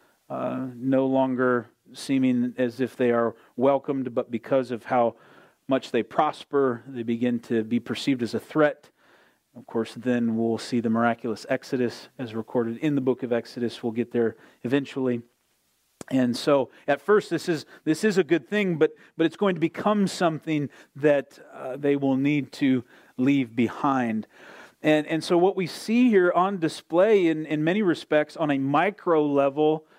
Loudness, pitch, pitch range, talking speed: -25 LUFS, 135 Hz, 120-155 Hz, 180 wpm